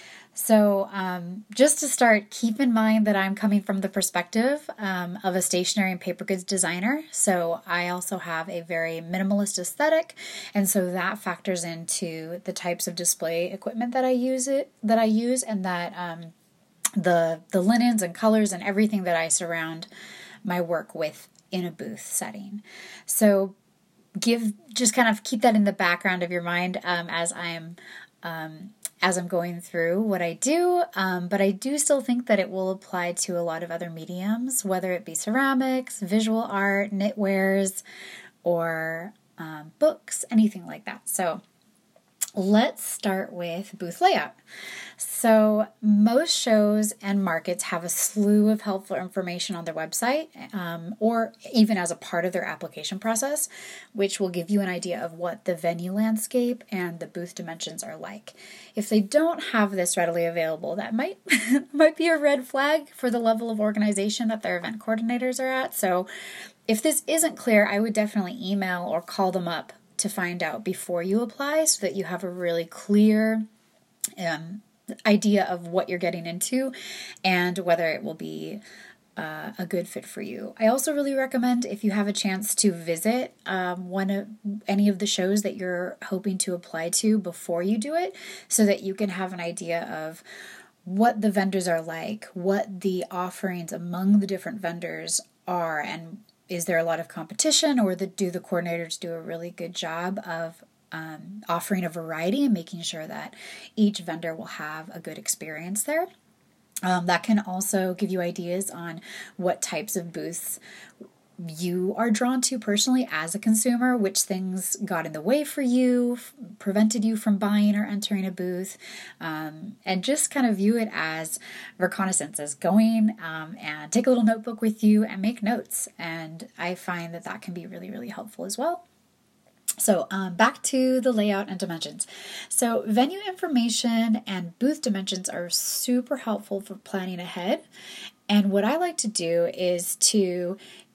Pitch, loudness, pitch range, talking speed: 195 Hz, -25 LUFS, 175-225 Hz, 180 wpm